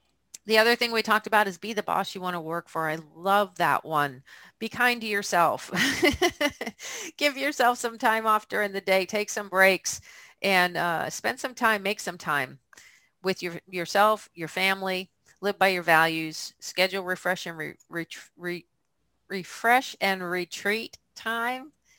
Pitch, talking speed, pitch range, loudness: 195 Hz, 165 wpm, 175-225 Hz, -26 LUFS